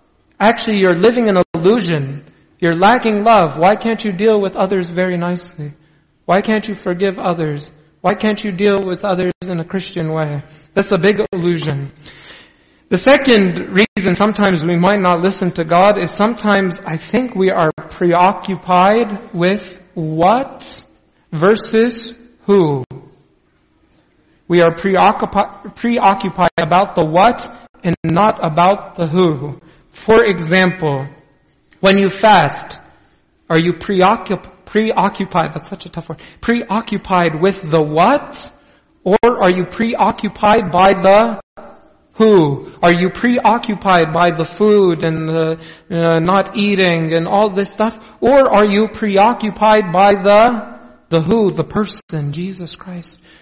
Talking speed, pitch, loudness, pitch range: 135 wpm, 190 Hz, -14 LUFS, 170-210 Hz